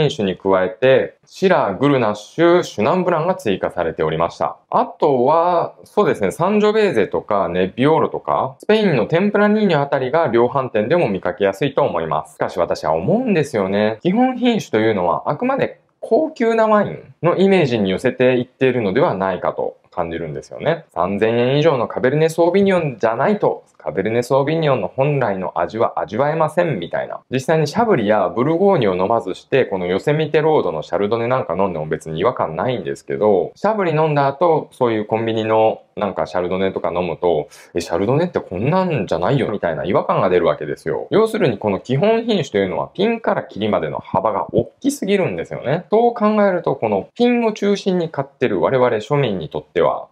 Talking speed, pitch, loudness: 445 characters per minute, 140 Hz, -18 LUFS